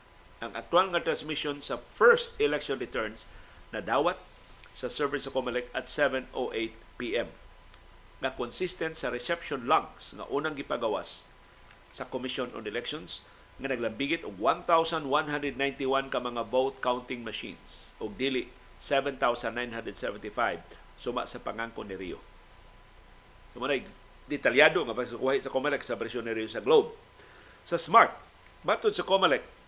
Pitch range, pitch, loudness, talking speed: 120-165 Hz, 135 Hz, -30 LUFS, 130 wpm